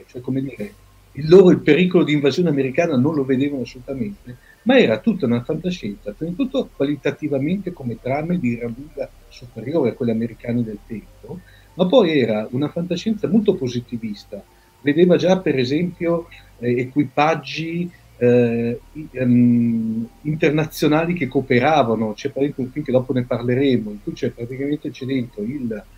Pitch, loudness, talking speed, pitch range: 140 Hz, -19 LUFS, 150 wpm, 120-165 Hz